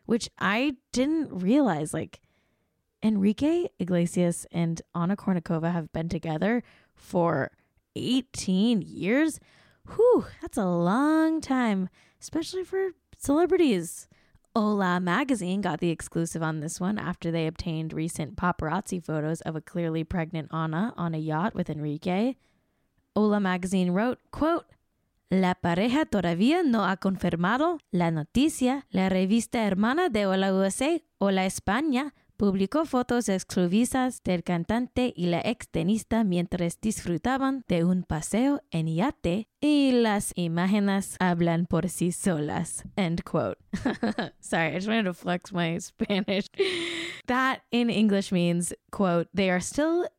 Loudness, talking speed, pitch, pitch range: -27 LUFS, 130 wpm, 195 Hz, 175-245 Hz